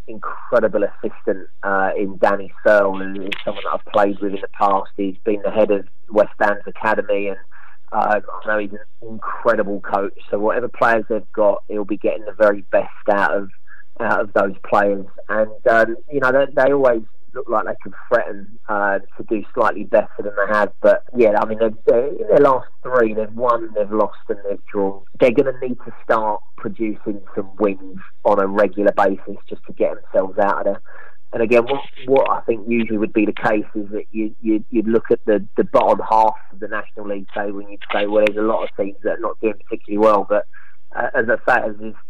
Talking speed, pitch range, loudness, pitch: 220 wpm, 100-115 Hz, -19 LUFS, 105 Hz